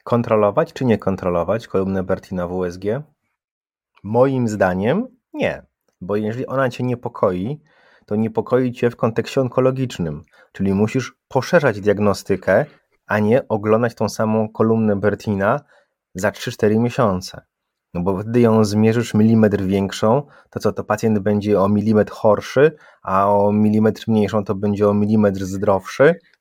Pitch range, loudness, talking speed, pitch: 100-120 Hz, -19 LUFS, 135 wpm, 105 Hz